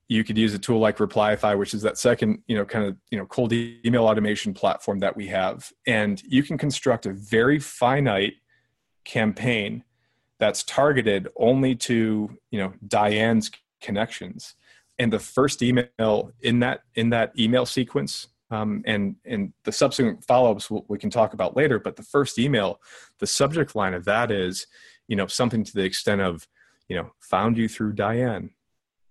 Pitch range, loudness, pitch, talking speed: 105-125 Hz, -23 LUFS, 110 Hz, 175 wpm